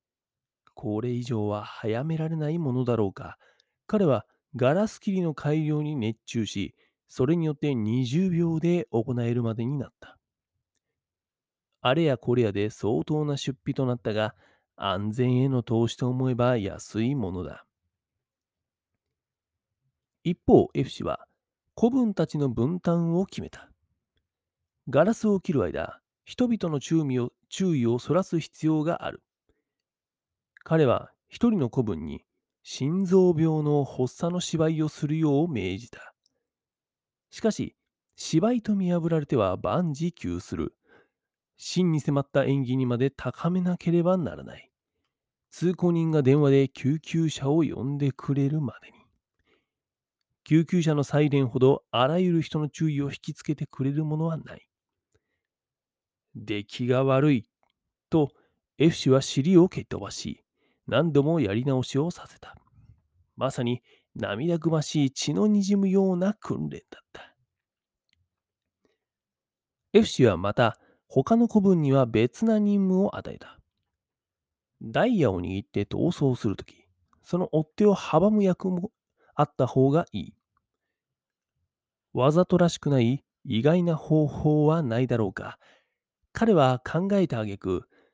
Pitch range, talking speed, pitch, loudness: 120-170 Hz, 245 characters per minute, 140 Hz, -26 LUFS